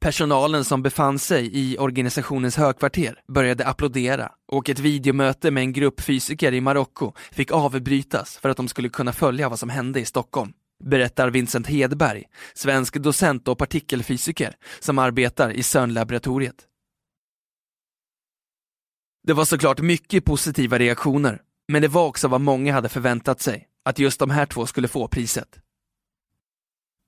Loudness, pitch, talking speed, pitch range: -22 LUFS, 135 Hz, 145 wpm, 125-145 Hz